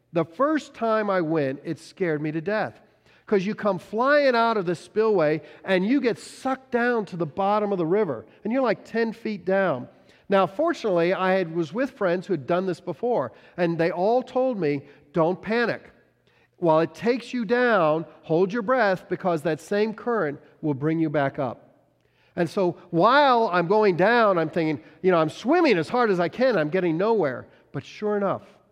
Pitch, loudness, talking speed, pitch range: 190 Hz, -24 LUFS, 195 wpm, 165-225 Hz